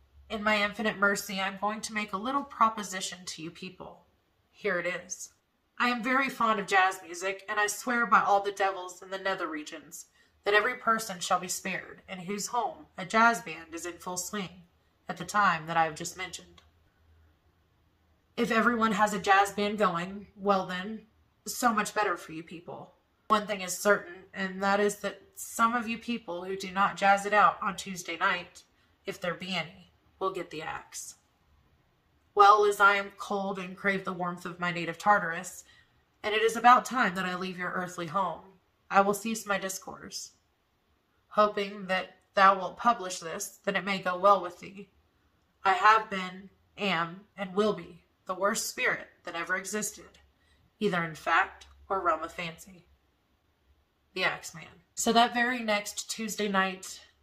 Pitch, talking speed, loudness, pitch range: 195 Hz, 185 wpm, -28 LUFS, 175-210 Hz